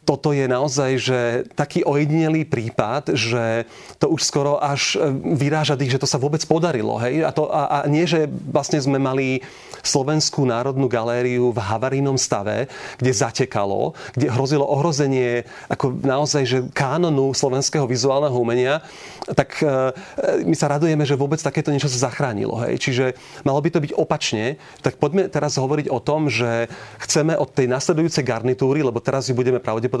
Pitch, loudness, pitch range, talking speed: 140 Hz, -20 LUFS, 130-150 Hz, 160 wpm